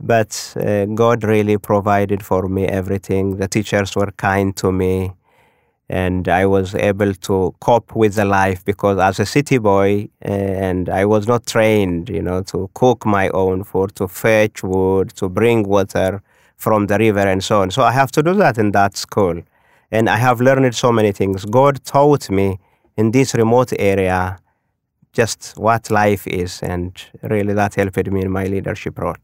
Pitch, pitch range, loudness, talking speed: 100 Hz, 95-110 Hz, -17 LUFS, 185 wpm